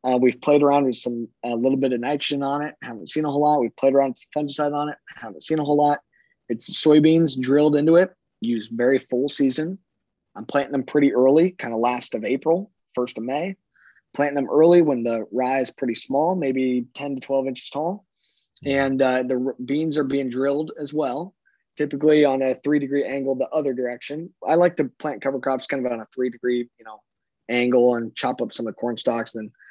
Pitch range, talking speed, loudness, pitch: 125-150 Hz, 225 wpm, -22 LUFS, 140 Hz